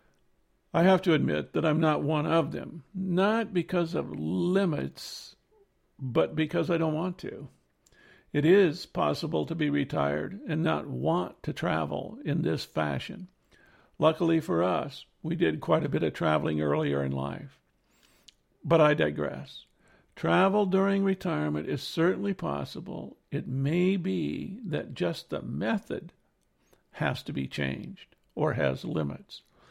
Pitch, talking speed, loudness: 160 Hz, 140 wpm, -28 LUFS